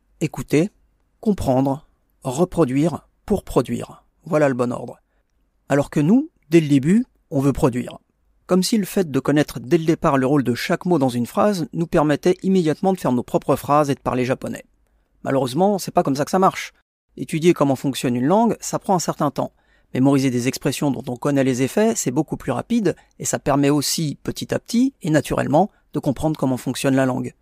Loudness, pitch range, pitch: -20 LUFS, 135-175 Hz, 145 Hz